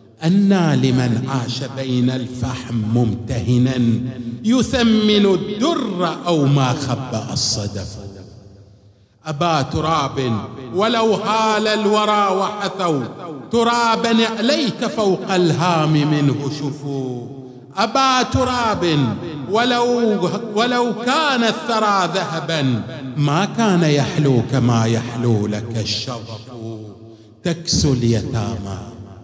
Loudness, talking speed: -18 LUFS, 80 wpm